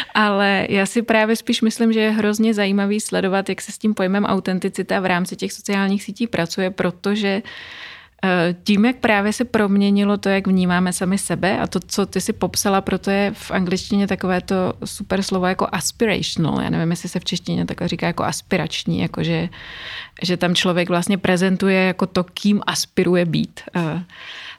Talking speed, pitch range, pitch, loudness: 175 wpm, 180-205 Hz, 195 Hz, -19 LUFS